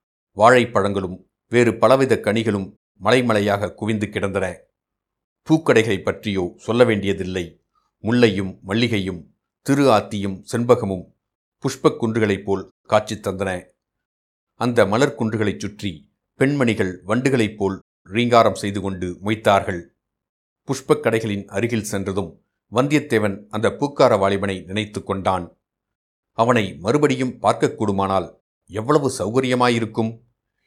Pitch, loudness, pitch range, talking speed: 105 Hz, -20 LUFS, 95-120 Hz, 90 wpm